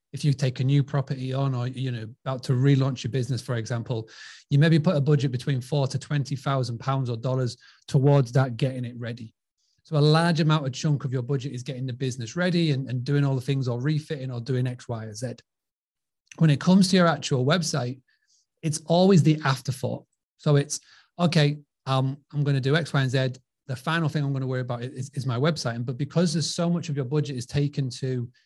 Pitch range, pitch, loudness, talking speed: 130-150 Hz, 135 Hz, -25 LUFS, 230 wpm